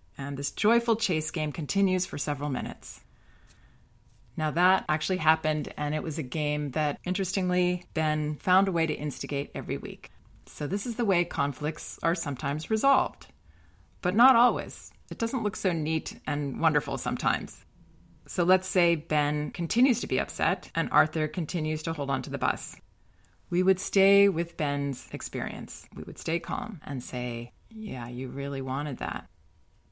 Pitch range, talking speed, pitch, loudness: 140-180 Hz, 165 wpm, 155 Hz, -28 LUFS